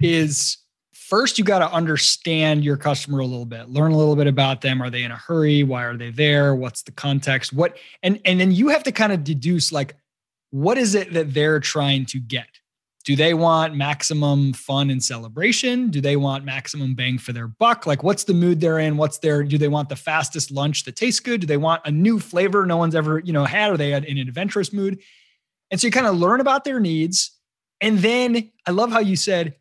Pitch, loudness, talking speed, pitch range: 155 Hz, -20 LUFS, 230 wpm, 140-190 Hz